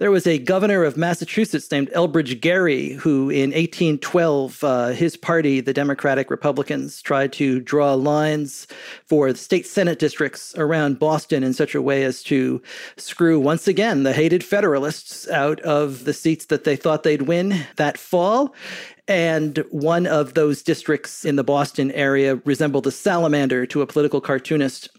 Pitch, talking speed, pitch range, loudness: 150 Hz, 165 wpm, 140-165 Hz, -20 LUFS